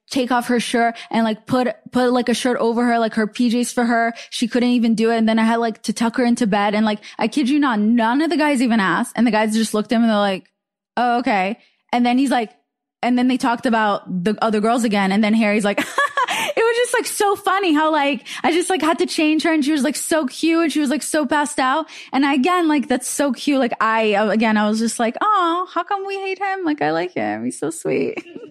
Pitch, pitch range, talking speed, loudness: 245 Hz, 225-300 Hz, 270 wpm, -18 LUFS